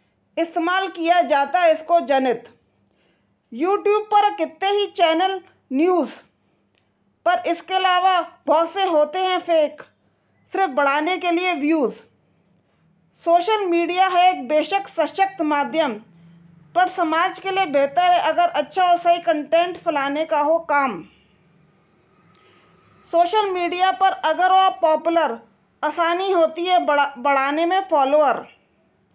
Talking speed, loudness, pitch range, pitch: 125 wpm, -19 LUFS, 295-365 Hz, 335 Hz